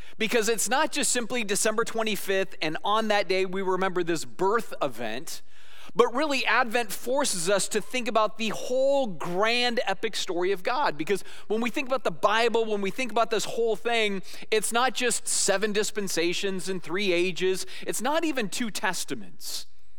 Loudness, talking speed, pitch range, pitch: -26 LUFS, 175 wpm, 190-245 Hz, 215 Hz